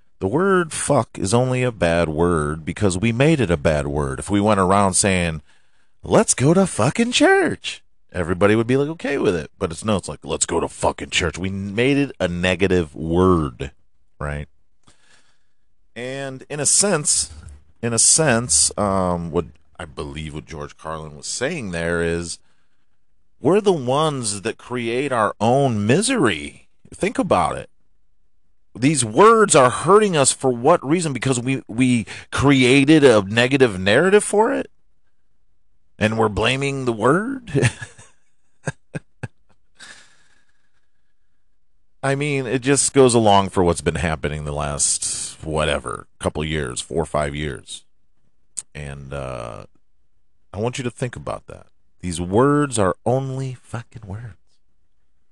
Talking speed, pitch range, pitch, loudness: 145 wpm, 85-130 Hz, 100 Hz, -19 LUFS